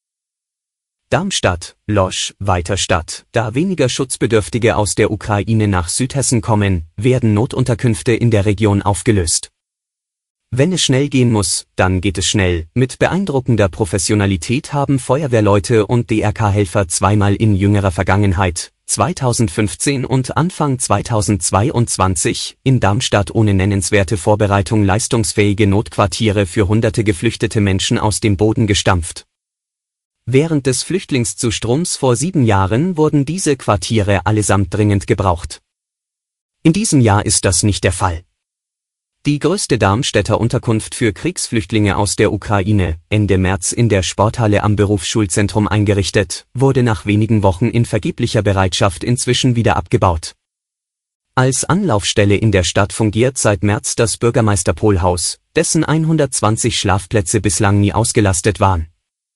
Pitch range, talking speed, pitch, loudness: 100-120 Hz, 120 wpm, 105 Hz, -15 LUFS